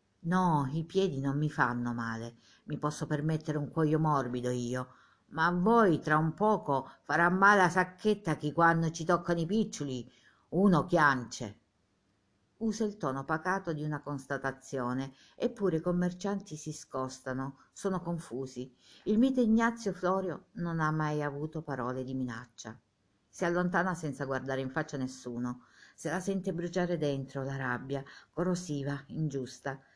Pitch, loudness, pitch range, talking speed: 150 Hz, -32 LUFS, 130-175 Hz, 150 wpm